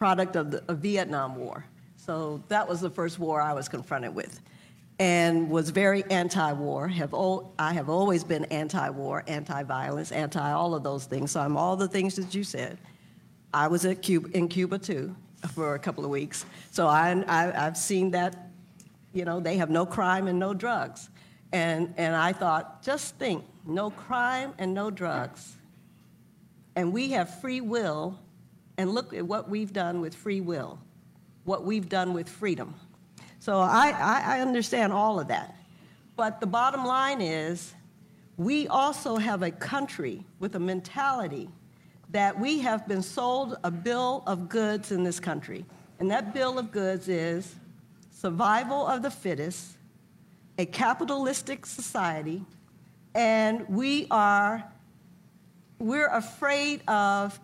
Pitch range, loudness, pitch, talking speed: 170-215 Hz, -28 LUFS, 185 Hz, 160 wpm